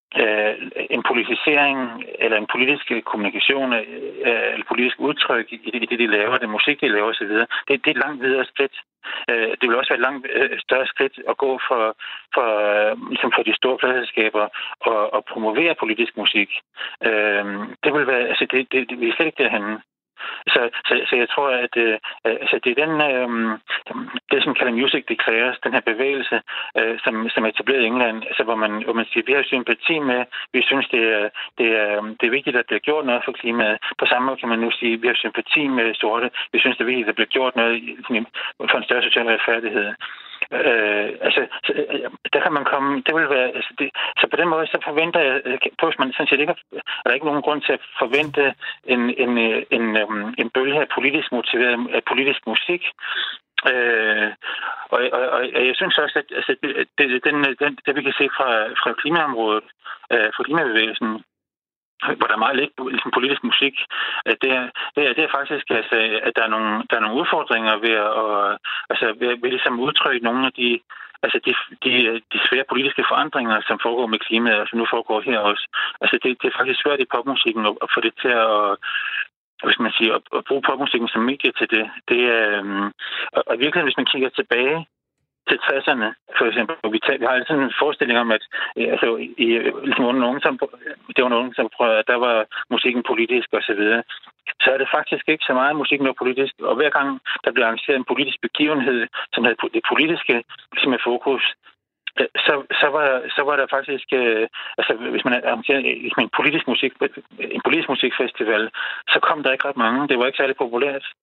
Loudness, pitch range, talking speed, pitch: -19 LUFS, 110-145 Hz, 205 wpm, 125 Hz